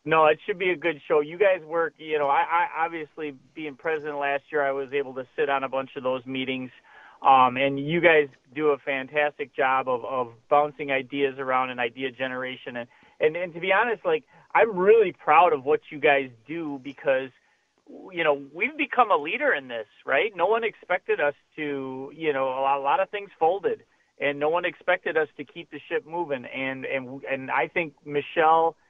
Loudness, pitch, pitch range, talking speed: -25 LUFS, 145 Hz, 135-170 Hz, 210 wpm